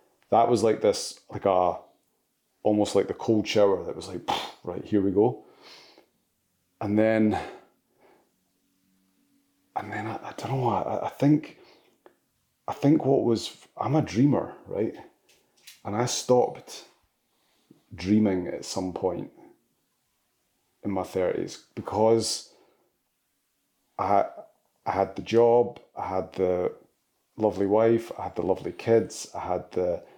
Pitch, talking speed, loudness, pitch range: 105 Hz, 130 wpm, -26 LUFS, 100-115 Hz